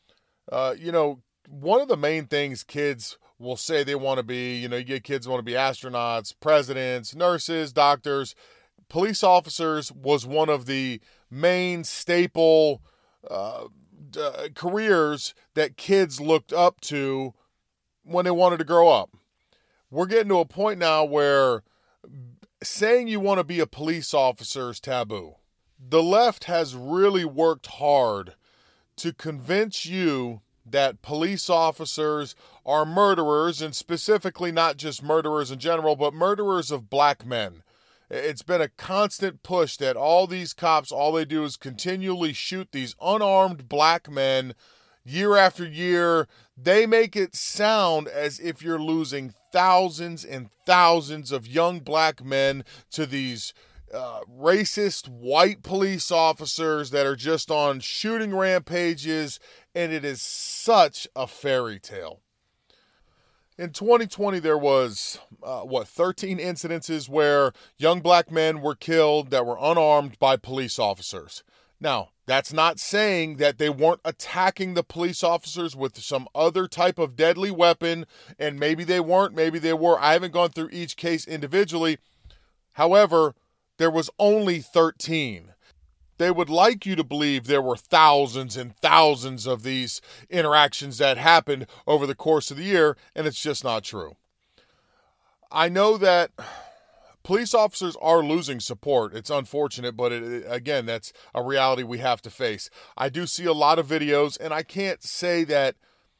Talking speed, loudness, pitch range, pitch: 150 wpm, -23 LUFS, 135-175 Hz, 155 Hz